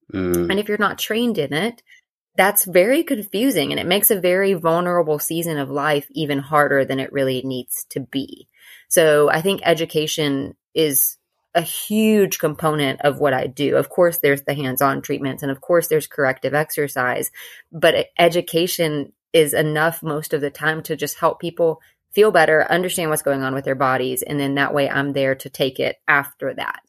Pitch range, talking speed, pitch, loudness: 140-175 Hz, 185 wpm, 155 Hz, -19 LUFS